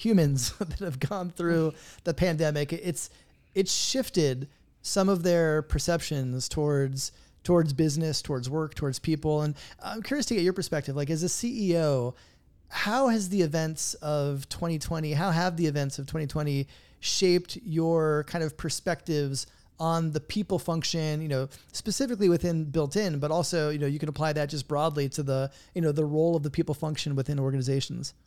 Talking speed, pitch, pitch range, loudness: 170 wpm, 155 Hz, 145-175 Hz, -28 LUFS